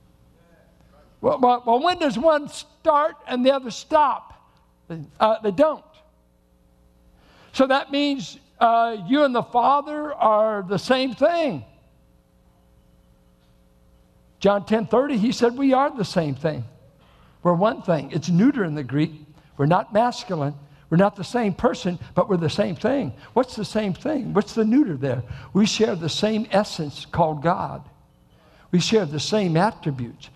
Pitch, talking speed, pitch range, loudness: 200 Hz, 150 wpm, 145-240 Hz, -22 LUFS